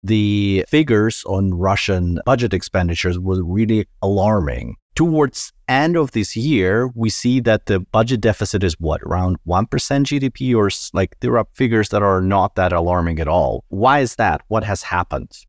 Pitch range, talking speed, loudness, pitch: 95-120 Hz, 165 wpm, -18 LUFS, 105 Hz